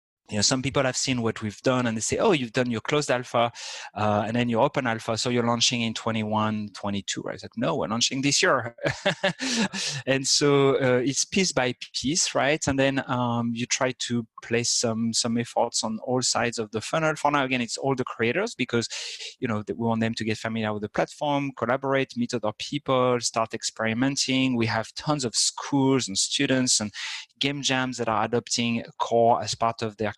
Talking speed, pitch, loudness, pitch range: 205 wpm, 120 Hz, -25 LUFS, 115-135 Hz